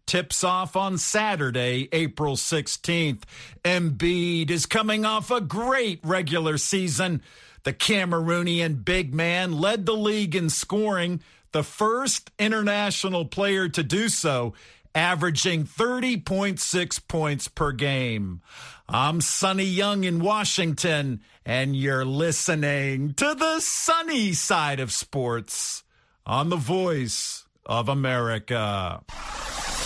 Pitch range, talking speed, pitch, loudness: 140-195 Hz, 110 wpm, 170 Hz, -24 LUFS